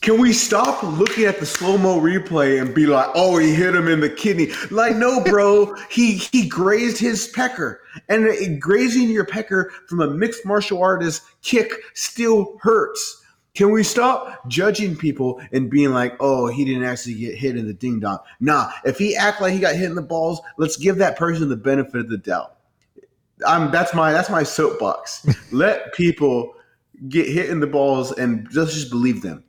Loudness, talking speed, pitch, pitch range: -19 LUFS, 190 wpm, 180 Hz, 145-215 Hz